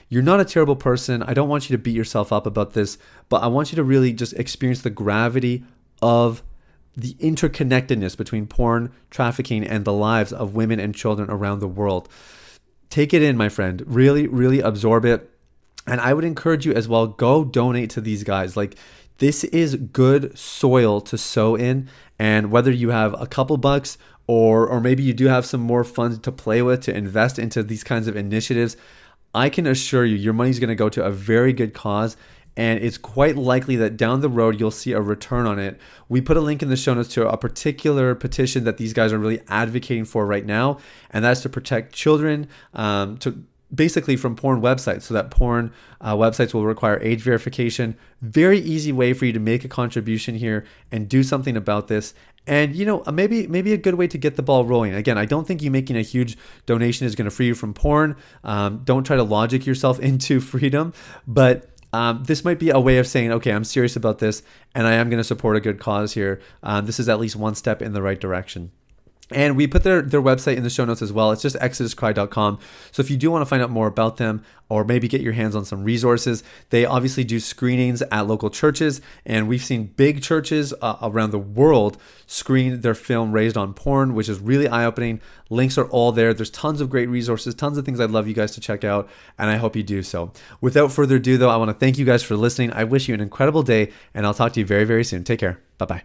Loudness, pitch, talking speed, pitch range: -20 LUFS, 120 Hz, 230 wpm, 110-130 Hz